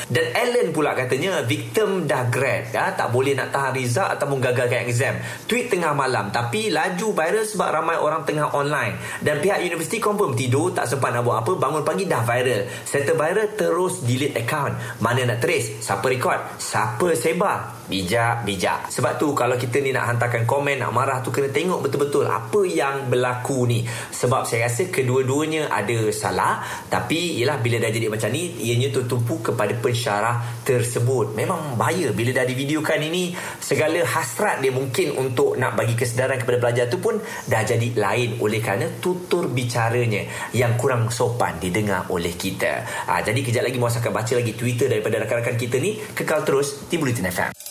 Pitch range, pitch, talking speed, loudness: 115-140 Hz, 125 Hz, 175 wpm, -22 LUFS